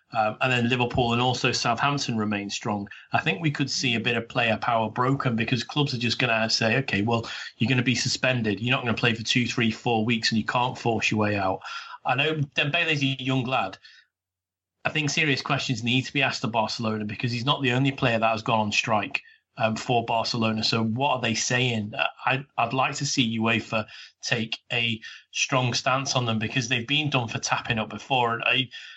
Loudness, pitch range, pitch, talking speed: -25 LUFS, 110-130 Hz, 120 Hz, 225 wpm